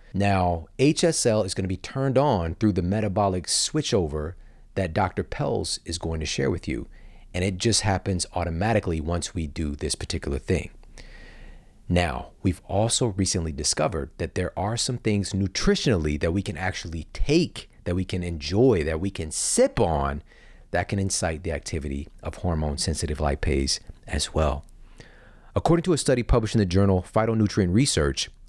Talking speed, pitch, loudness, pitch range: 165 wpm, 95 Hz, -25 LUFS, 80-105 Hz